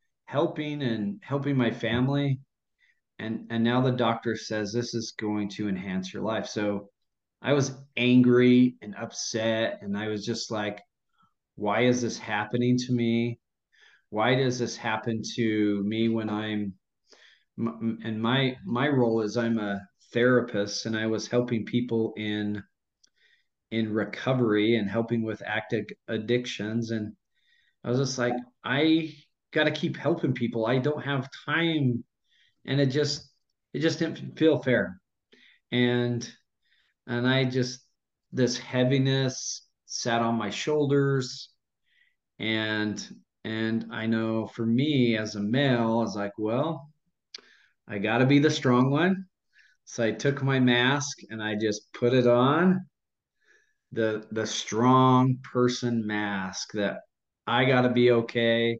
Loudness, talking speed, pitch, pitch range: -27 LUFS, 140 wpm, 120 Hz, 110-130 Hz